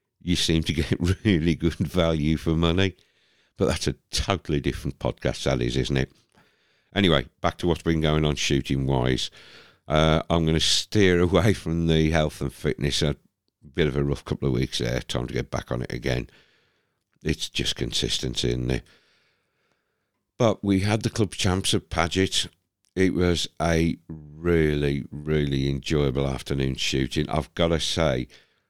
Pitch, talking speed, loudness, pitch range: 80 Hz, 165 wpm, -24 LUFS, 70-90 Hz